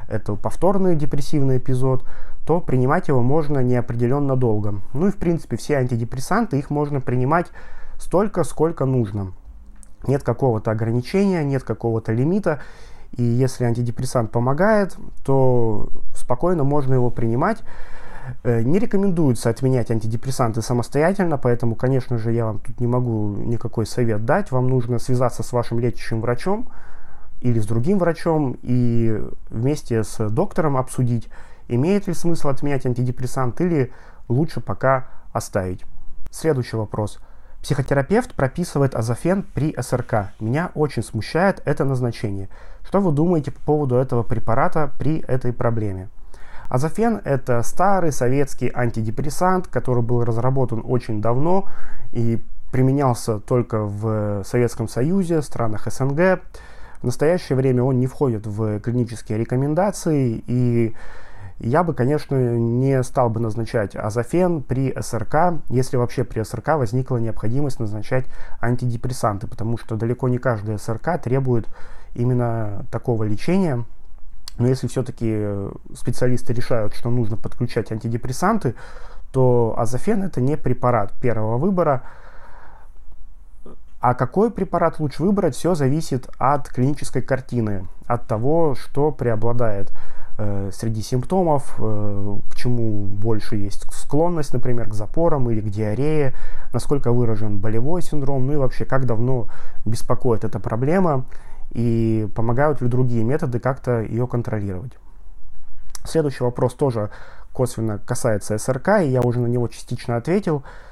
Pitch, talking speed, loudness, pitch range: 125 Hz, 125 wpm, -22 LUFS, 115-145 Hz